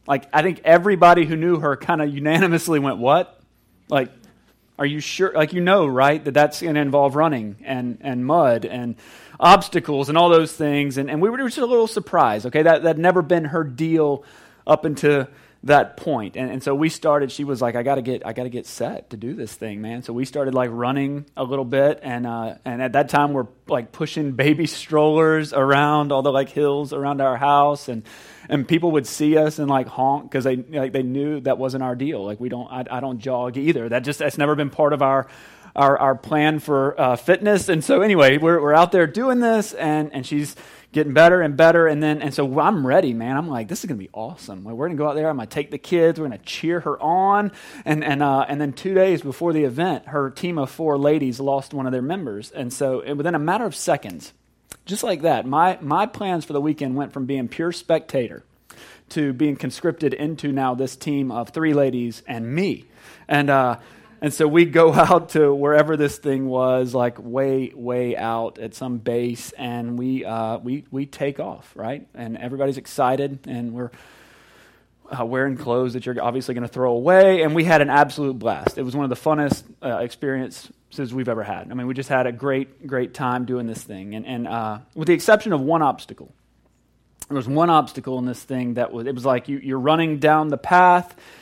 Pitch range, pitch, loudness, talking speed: 130-155 Hz, 140 Hz, -20 LUFS, 225 wpm